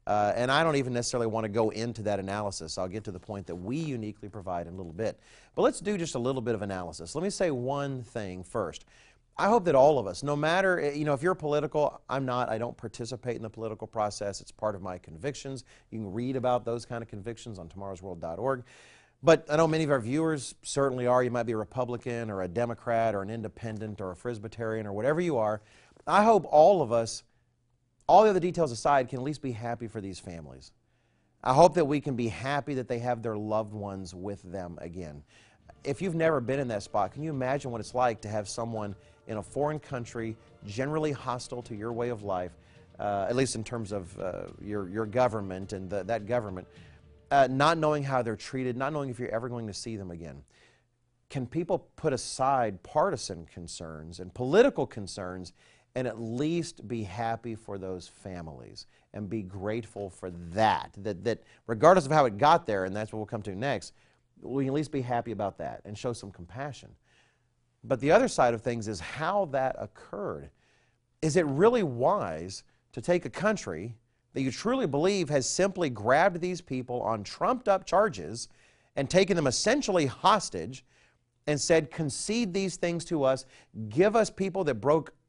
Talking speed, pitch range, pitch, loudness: 205 wpm, 105-140 Hz, 120 Hz, -29 LUFS